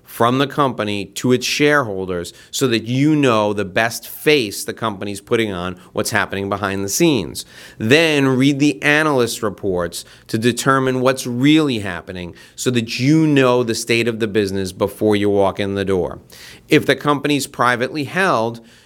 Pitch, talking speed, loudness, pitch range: 120 Hz, 165 wpm, -17 LUFS, 100-140 Hz